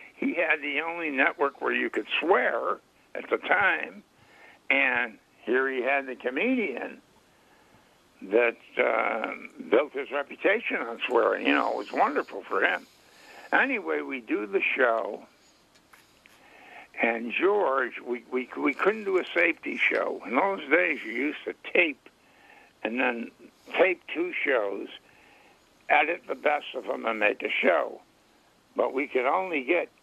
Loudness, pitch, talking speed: -26 LUFS, 195 Hz, 145 wpm